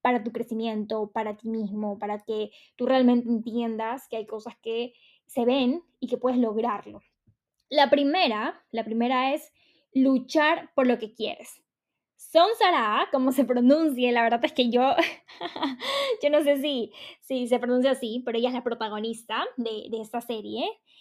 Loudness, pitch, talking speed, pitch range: -26 LUFS, 245 Hz, 165 wpm, 225-275 Hz